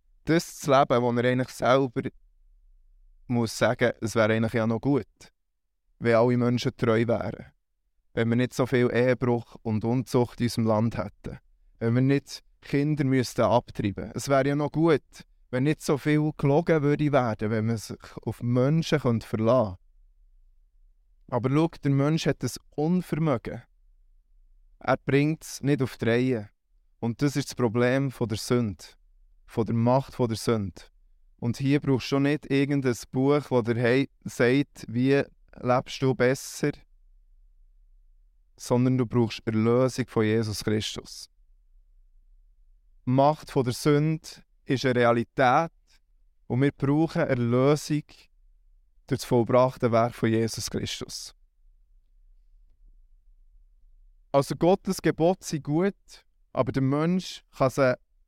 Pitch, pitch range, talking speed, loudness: 120 Hz, 85-135 Hz, 140 wpm, -26 LUFS